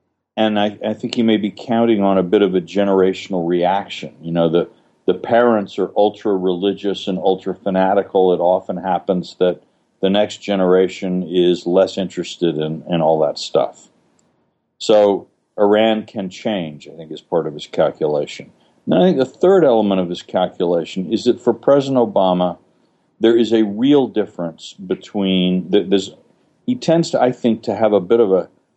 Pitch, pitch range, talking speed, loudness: 100 Hz, 90-110 Hz, 175 wpm, -17 LUFS